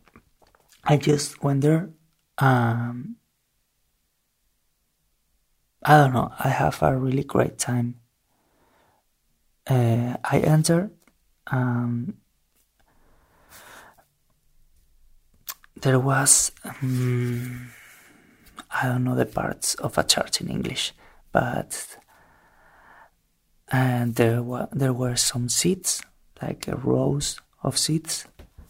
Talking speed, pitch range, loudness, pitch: 90 wpm, 120-145 Hz, -23 LUFS, 130 Hz